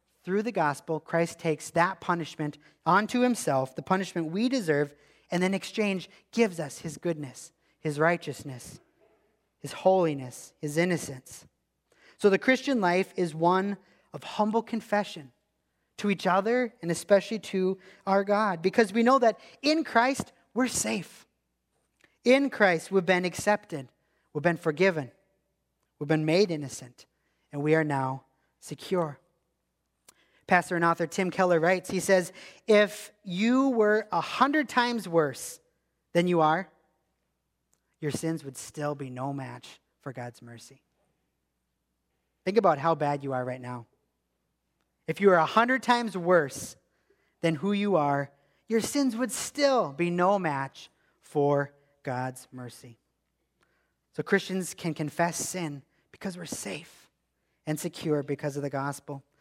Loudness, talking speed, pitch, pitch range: -27 LUFS, 140 wpm, 170 Hz, 145-200 Hz